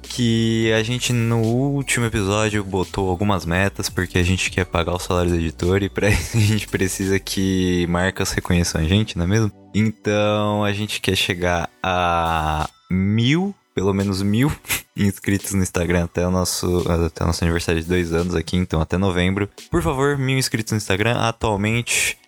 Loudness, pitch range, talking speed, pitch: -20 LUFS, 90-110 Hz, 180 wpm, 100 Hz